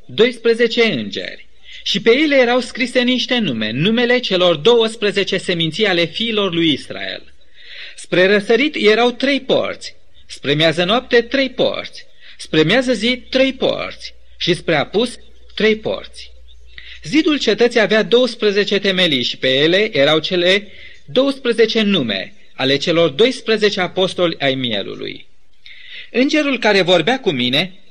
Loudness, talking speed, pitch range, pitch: -15 LUFS, 130 wpm, 180-245 Hz, 220 Hz